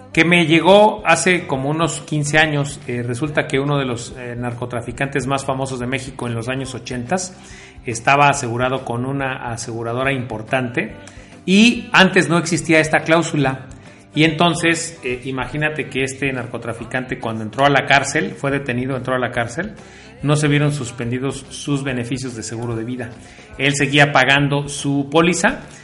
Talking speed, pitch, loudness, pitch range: 160 wpm, 135 Hz, -18 LUFS, 120-155 Hz